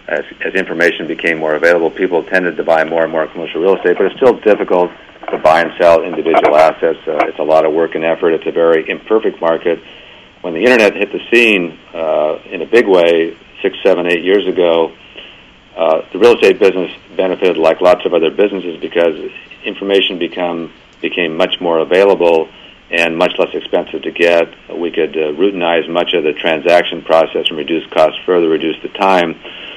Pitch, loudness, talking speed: 95 Hz, -13 LUFS, 190 wpm